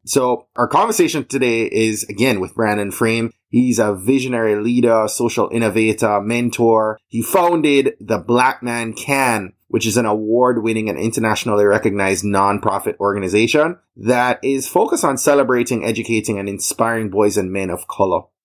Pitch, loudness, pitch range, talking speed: 115 Hz, -17 LUFS, 105-125 Hz, 145 wpm